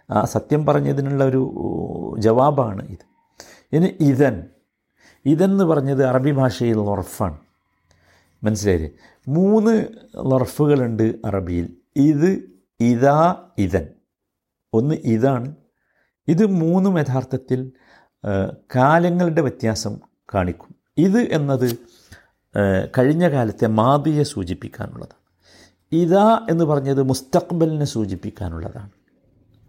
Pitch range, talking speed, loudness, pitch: 105-155 Hz, 80 wpm, -19 LUFS, 130 Hz